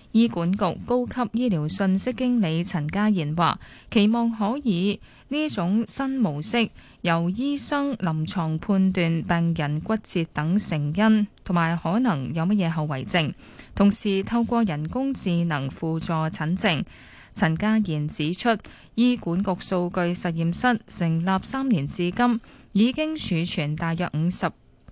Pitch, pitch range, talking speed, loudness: 190 Hz, 165-225 Hz, 210 characters per minute, -24 LUFS